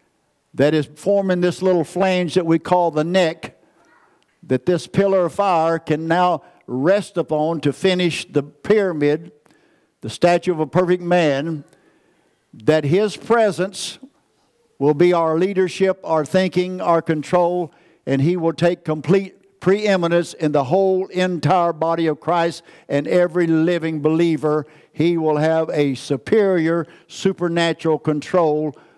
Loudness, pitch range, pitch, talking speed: -19 LUFS, 155-185 Hz, 170 Hz, 135 wpm